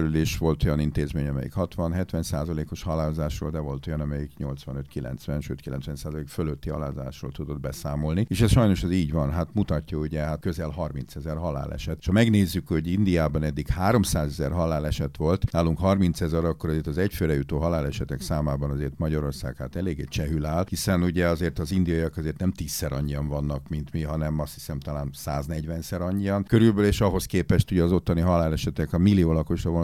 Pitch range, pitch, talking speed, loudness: 75-90 Hz, 80 Hz, 175 wpm, -26 LUFS